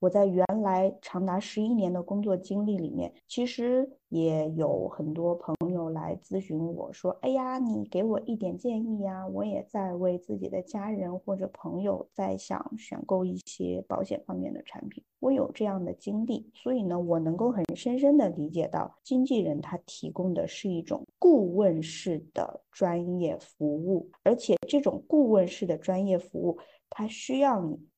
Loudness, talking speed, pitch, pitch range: -29 LUFS, 255 characters per minute, 190 Hz, 170-225 Hz